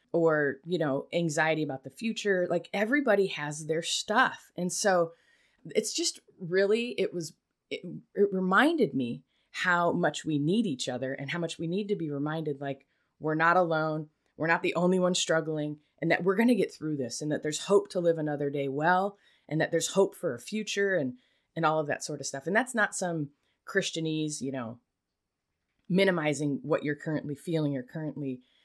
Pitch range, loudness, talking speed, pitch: 150-195 Hz, -29 LUFS, 195 wpm, 165 Hz